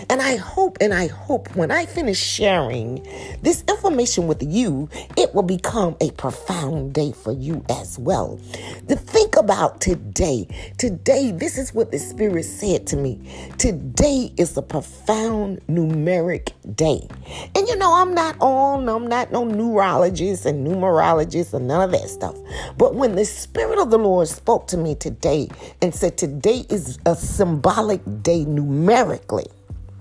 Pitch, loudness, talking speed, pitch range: 180 Hz, -20 LUFS, 160 wpm, 145-230 Hz